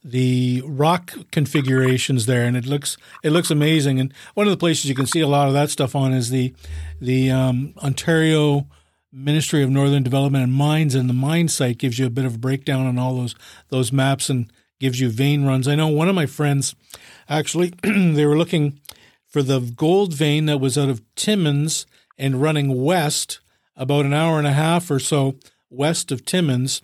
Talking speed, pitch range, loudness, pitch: 200 wpm, 130-155 Hz, -20 LUFS, 140 Hz